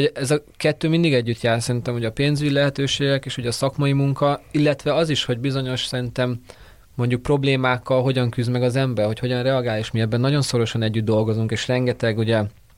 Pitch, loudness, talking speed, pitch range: 125 Hz, -21 LUFS, 195 wpm, 115-140 Hz